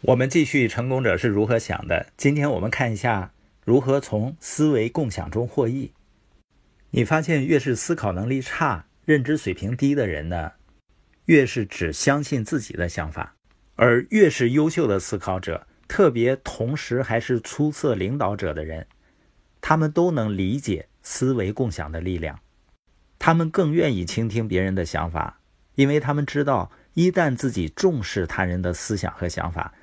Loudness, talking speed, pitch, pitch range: -23 LUFS, 250 characters per minute, 120 Hz, 95-145 Hz